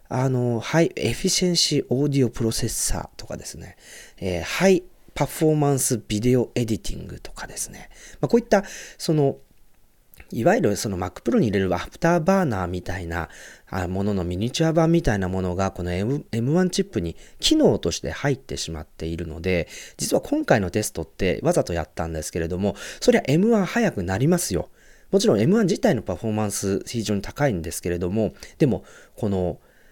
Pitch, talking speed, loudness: 115 Hz, 395 characters per minute, -23 LUFS